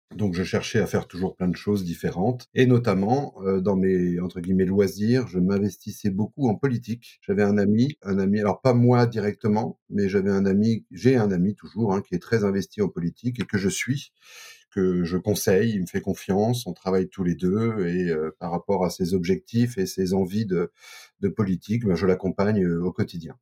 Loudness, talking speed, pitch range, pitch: -24 LUFS, 210 wpm, 95-115 Hz, 100 Hz